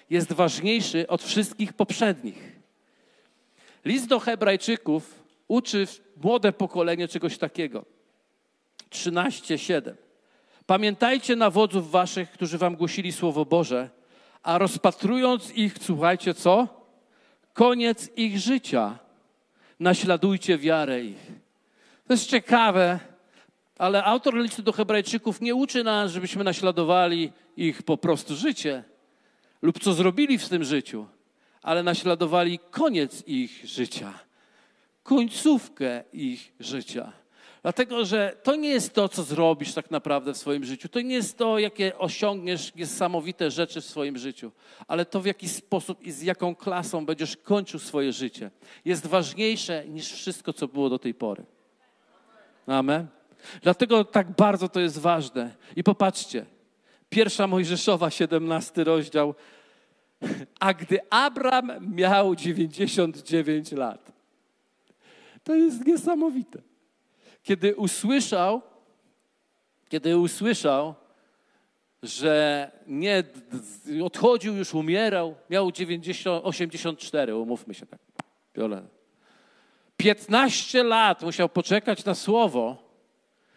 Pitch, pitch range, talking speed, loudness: 185 Hz, 165-220 Hz, 110 wpm, -25 LUFS